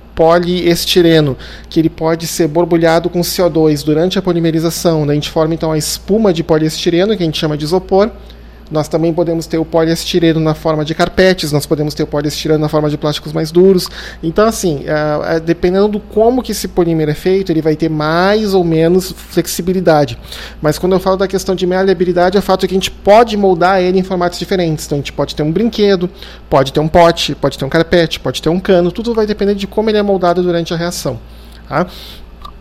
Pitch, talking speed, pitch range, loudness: 170 Hz, 210 wpm, 155-185 Hz, -13 LUFS